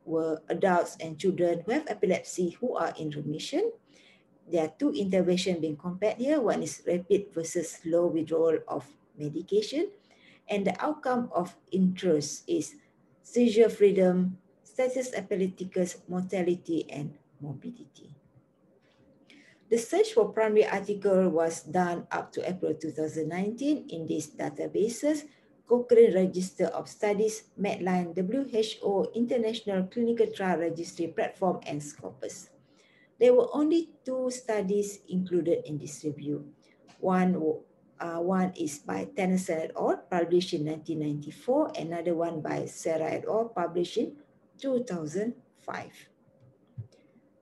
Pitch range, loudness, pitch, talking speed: 165-225 Hz, -29 LUFS, 185 Hz, 120 wpm